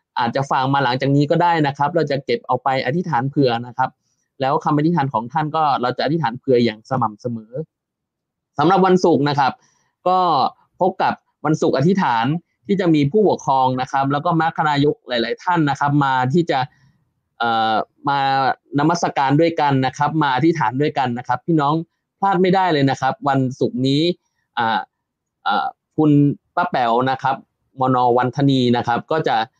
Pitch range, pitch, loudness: 130-160 Hz, 140 Hz, -18 LUFS